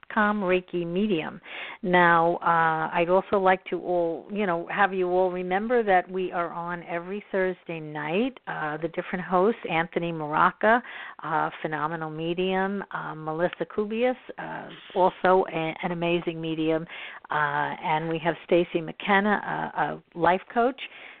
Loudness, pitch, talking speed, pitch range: -26 LUFS, 180 Hz, 145 wpm, 170-190 Hz